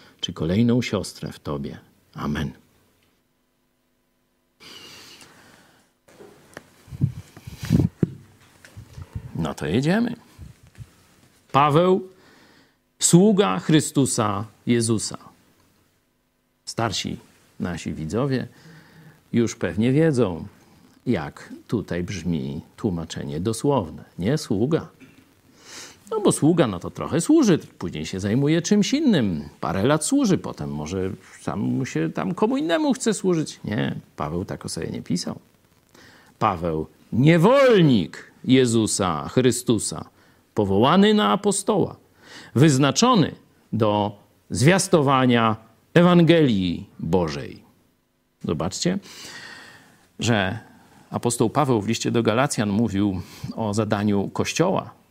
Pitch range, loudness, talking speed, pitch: 100-165 Hz, -22 LUFS, 90 wpm, 120 Hz